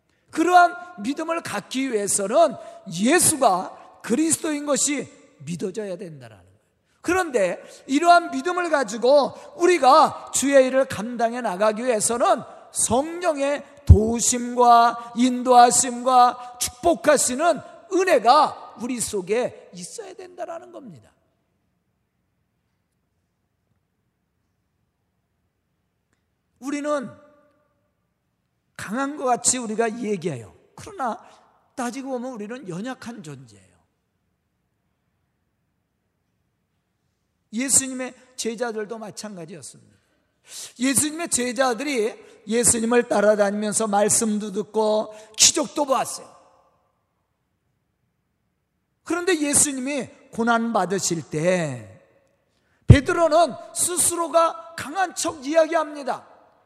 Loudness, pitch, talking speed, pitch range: -20 LUFS, 250 Hz, 215 characters per minute, 215-320 Hz